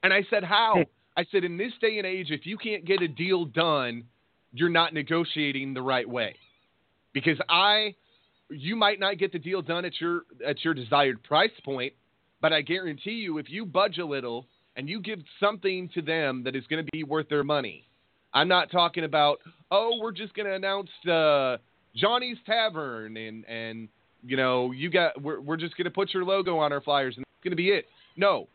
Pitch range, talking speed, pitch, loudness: 140-195 Hz, 210 wpm, 165 Hz, -27 LUFS